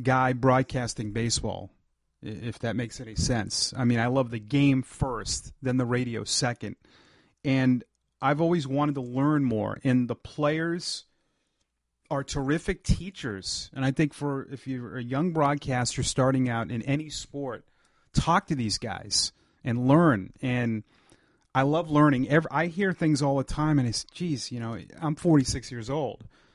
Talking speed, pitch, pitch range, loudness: 165 wpm, 130 Hz, 115-145 Hz, -27 LUFS